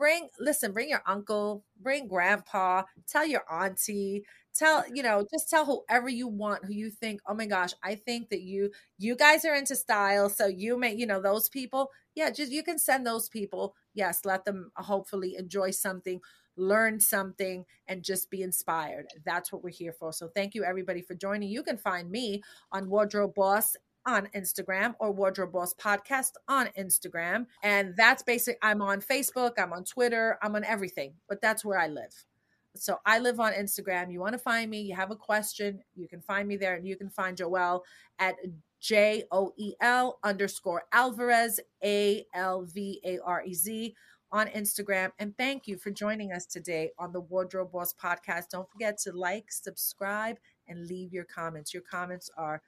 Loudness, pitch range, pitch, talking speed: -30 LUFS, 185-225 Hz, 200 Hz, 190 wpm